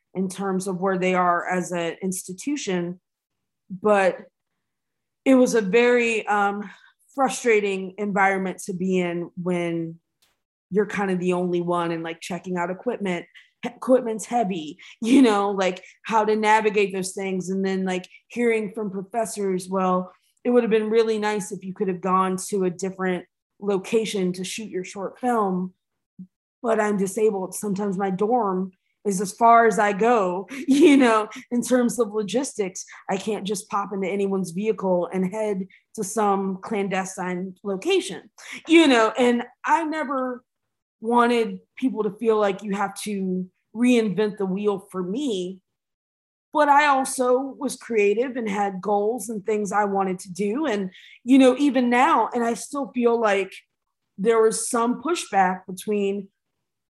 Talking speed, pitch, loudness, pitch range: 155 wpm, 205 Hz, -23 LUFS, 185-230 Hz